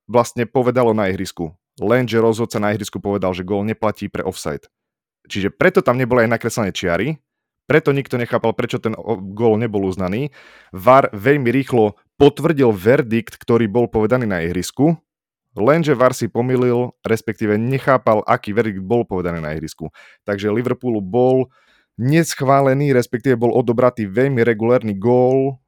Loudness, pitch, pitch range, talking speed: -17 LUFS, 115 Hz, 105-125 Hz, 145 wpm